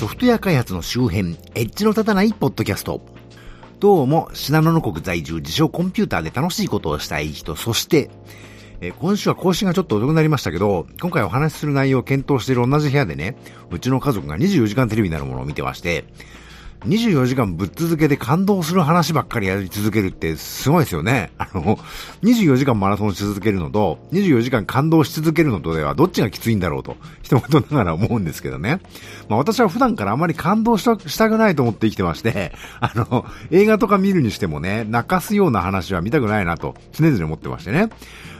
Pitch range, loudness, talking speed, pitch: 100-165 Hz, -19 LUFS, 420 characters per minute, 125 Hz